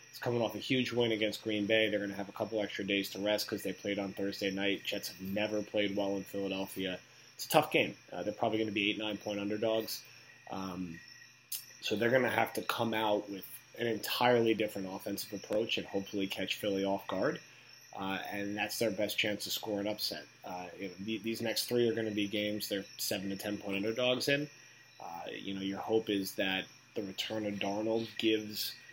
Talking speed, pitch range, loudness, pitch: 220 wpm, 100-110 Hz, -34 LUFS, 105 Hz